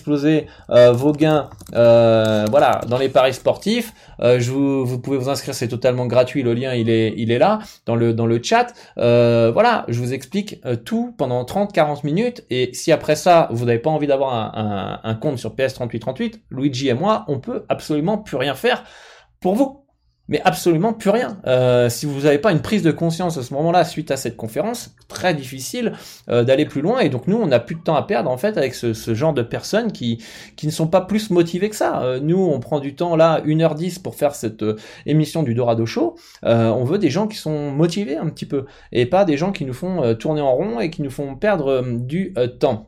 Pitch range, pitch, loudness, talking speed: 120-175 Hz, 145 Hz, -19 LUFS, 230 wpm